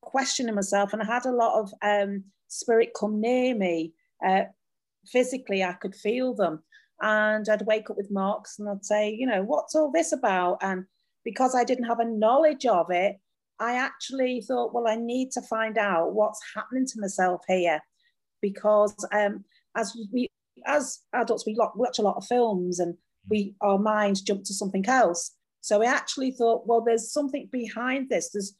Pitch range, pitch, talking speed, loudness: 200-250 Hz, 220 Hz, 185 wpm, -26 LUFS